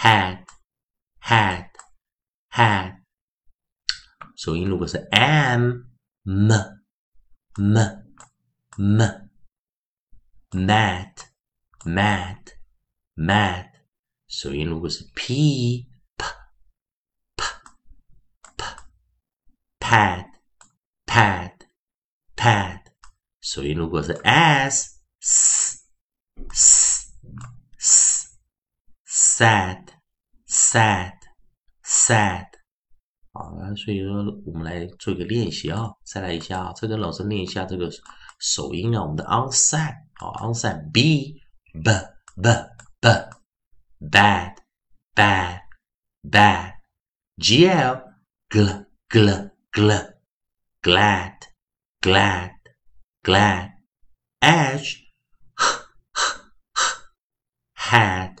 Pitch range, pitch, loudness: 90-115 Hz, 100 Hz, -19 LUFS